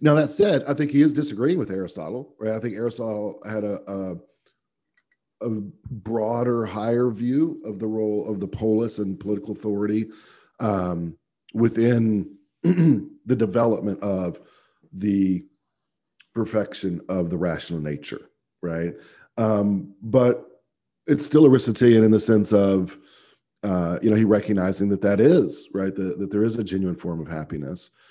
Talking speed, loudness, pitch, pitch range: 145 wpm, -22 LUFS, 105 Hz, 95-115 Hz